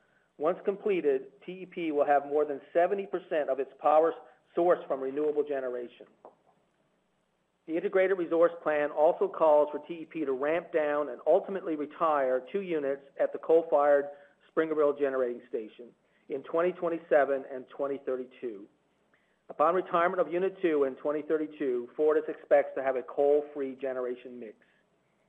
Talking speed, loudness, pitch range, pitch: 135 wpm, -29 LUFS, 140-170 Hz, 150 Hz